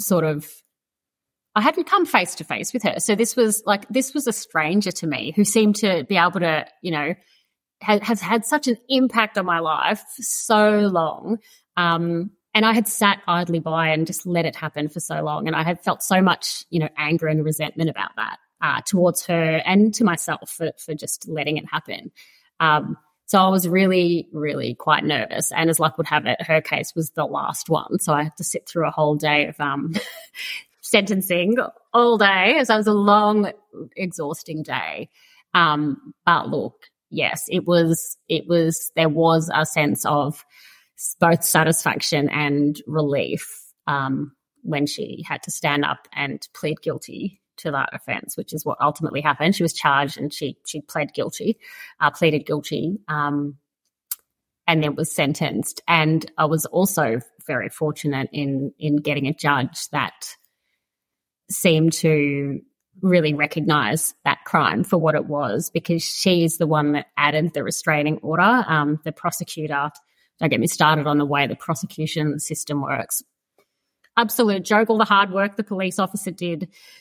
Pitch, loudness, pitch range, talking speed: 165 Hz, -21 LUFS, 150-195 Hz, 175 wpm